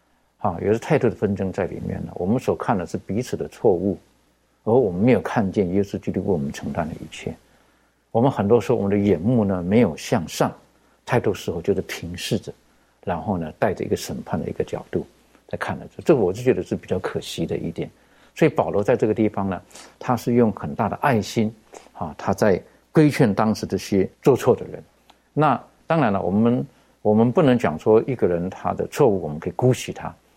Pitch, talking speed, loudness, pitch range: 110 Hz, 310 characters per minute, -22 LUFS, 100-120 Hz